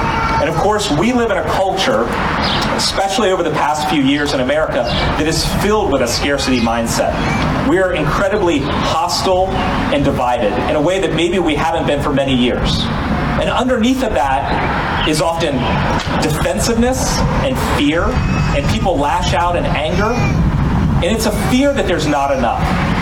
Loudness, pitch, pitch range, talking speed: -15 LUFS, 165 Hz, 140-195 Hz, 165 wpm